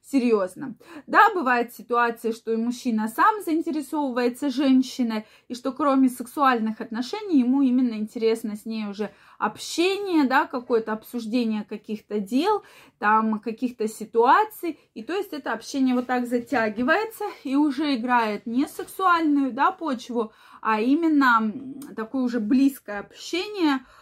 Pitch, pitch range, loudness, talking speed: 255 Hz, 225-295 Hz, -24 LUFS, 125 wpm